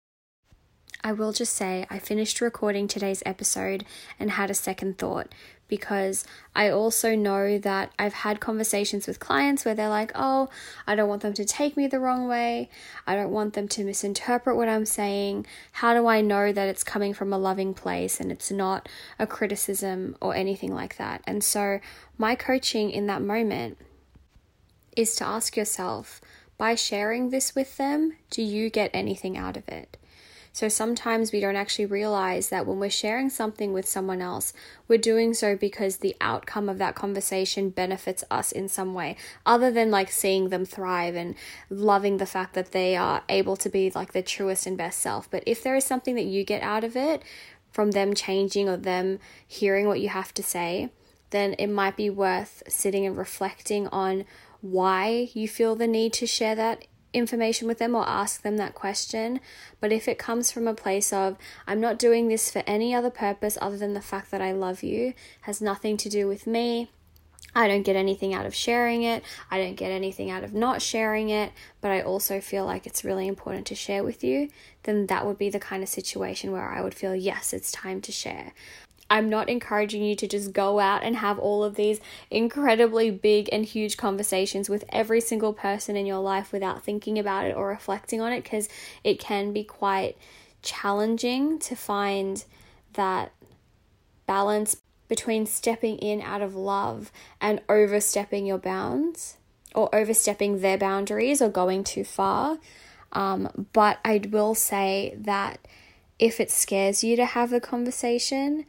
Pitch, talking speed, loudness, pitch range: 205 Hz, 185 wpm, -26 LUFS, 195-225 Hz